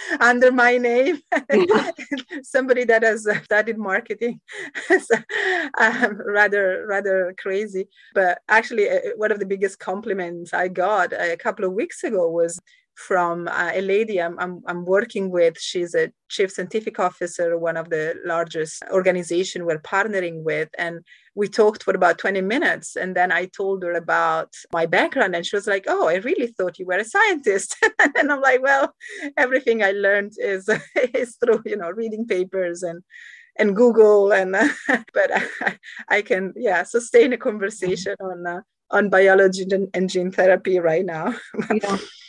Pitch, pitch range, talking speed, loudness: 200 Hz, 180-245 Hz, 165 wpm, -20 LUFS